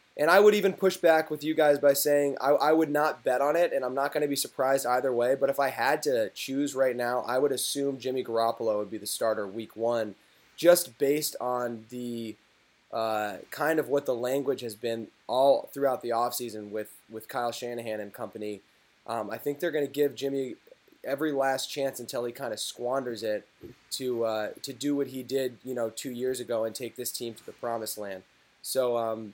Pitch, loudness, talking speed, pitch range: 125 Hz, -28 LUFS, 220 wpm, 115-140 Hz